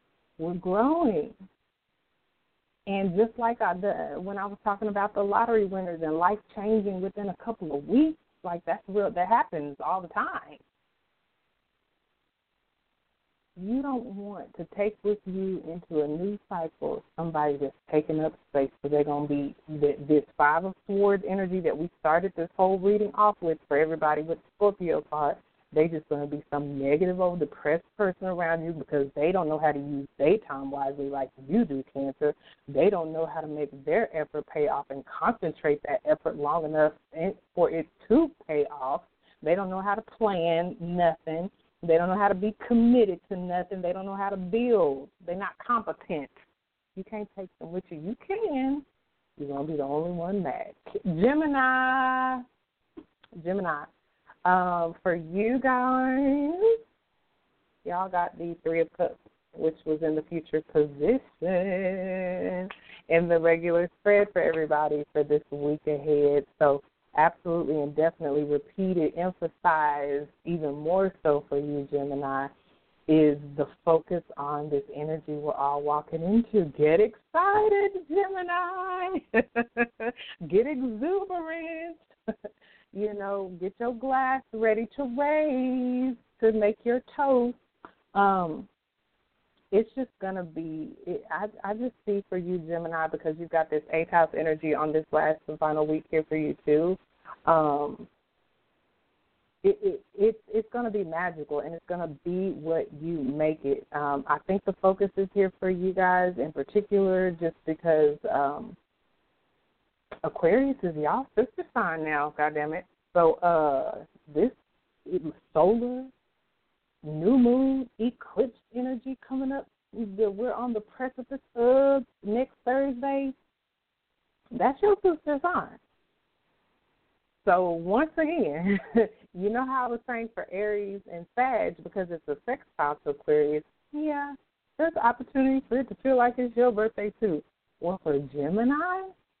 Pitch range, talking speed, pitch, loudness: 155-230 Hz, 150 wpm, 185 Hz, -27 LUFS